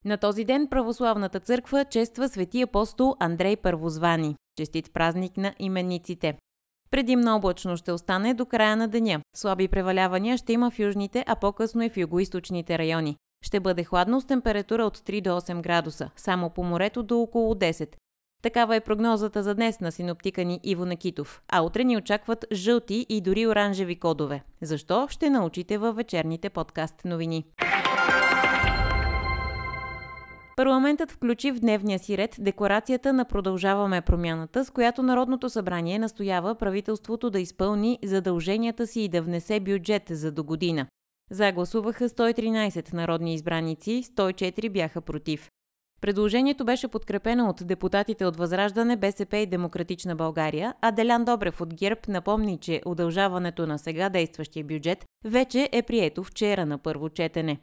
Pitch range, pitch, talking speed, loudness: 170-225 Hz, 195 Hz, 145 wpm, -26 LUFS